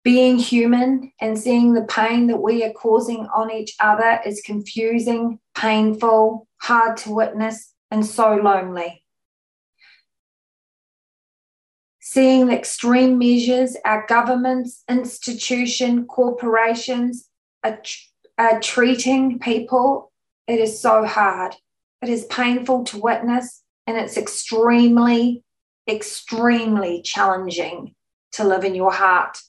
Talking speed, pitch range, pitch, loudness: 110 wpm, 215-245 Hz, 230 Hz, -18 LUFS